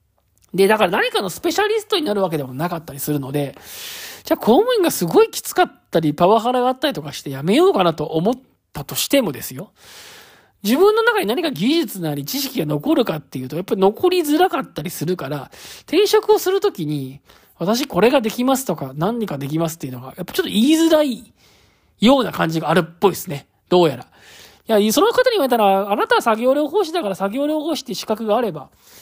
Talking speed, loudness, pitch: 435 characters per minute, -18 LUFS, 220 Hz